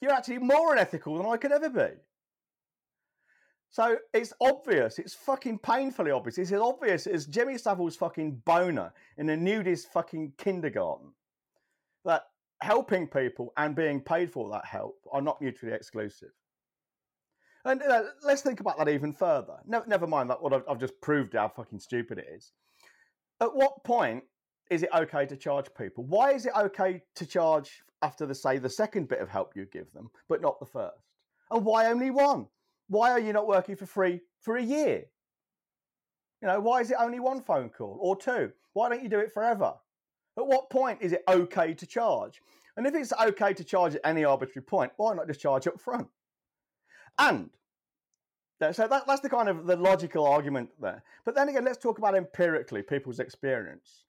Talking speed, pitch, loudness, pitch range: 185 wpm, 195 Hz, -29 LUFS, 160-250 Hz